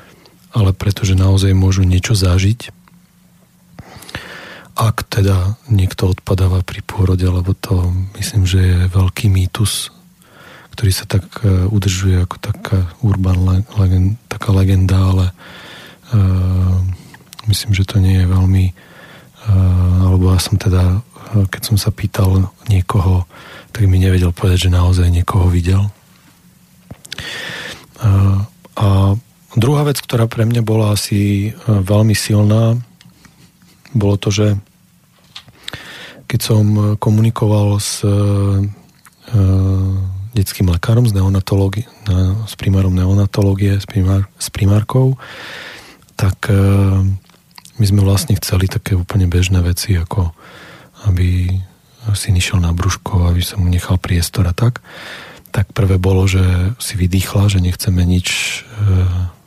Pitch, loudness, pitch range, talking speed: 100 Hz, -15 LUFS, 95-105 Hz, 115 wpm